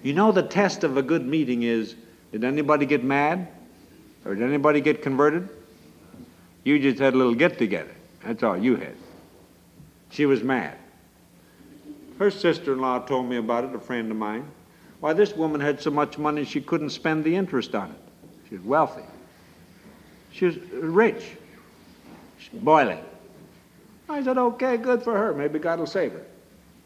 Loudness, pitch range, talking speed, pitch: -24 LUFS, 130-175 Hz, 170 wpm, 150 Hz